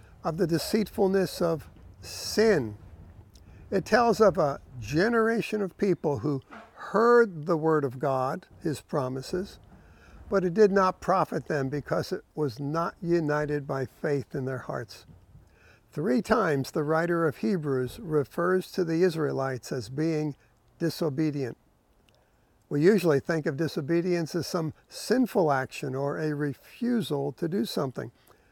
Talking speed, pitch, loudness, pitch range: 135 wpm, 155 Hz, -27 LUFS, 135-185 Hz